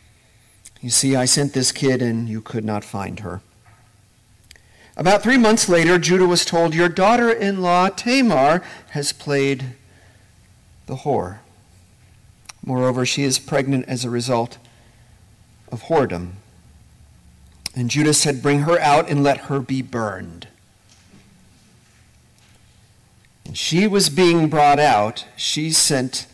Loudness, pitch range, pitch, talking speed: -18 LUFS, 105-150 Hz, 125 Hz, 130 wpm